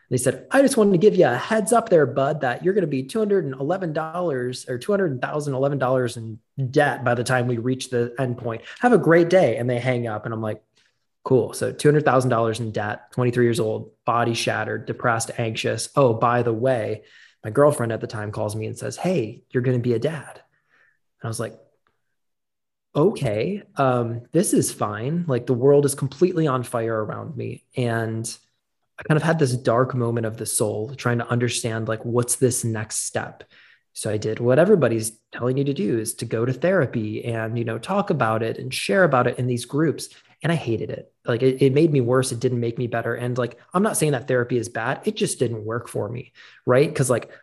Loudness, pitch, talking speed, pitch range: -22 LUFS, 125 Hz, 215 wpm, 115-145 Hz